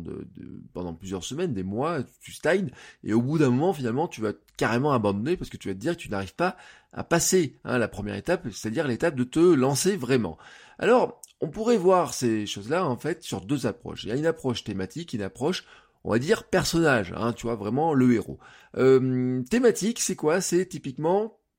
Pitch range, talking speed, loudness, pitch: 110-170 Hz, 210 wpm, -26 LUFS, 130 Hz